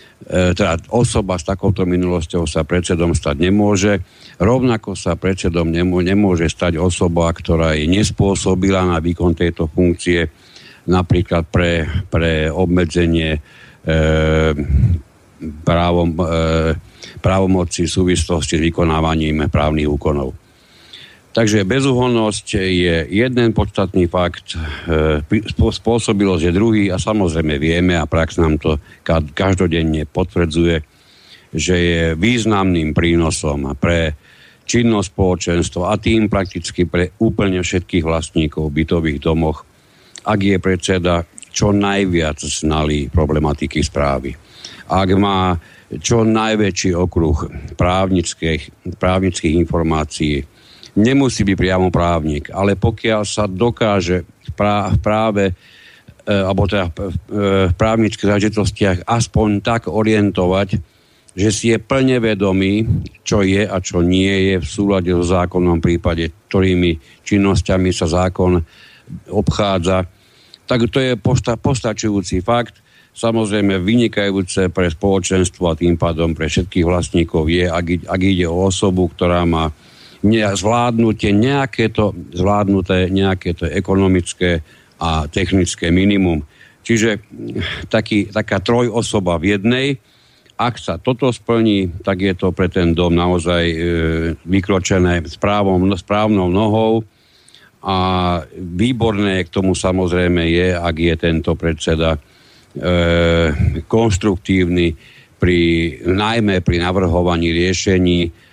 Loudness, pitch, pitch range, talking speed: -16 LUFS, 90 Hz, 85-105 Hz, 110 wpm